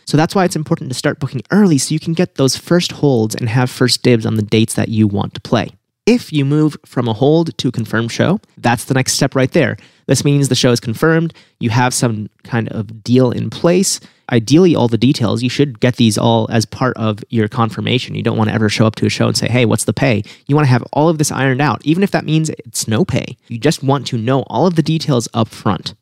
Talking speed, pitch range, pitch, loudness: 265 wpm, 115-150 Hz, 125 Hz, -15 LUFS